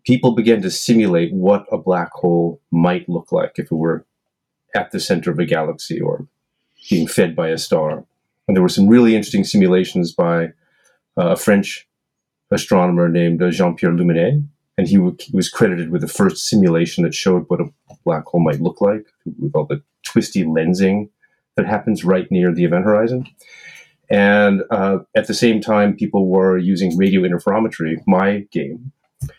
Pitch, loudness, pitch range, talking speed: 95 Hz, -17 LUFS, 85-115 Hz, 175 wpm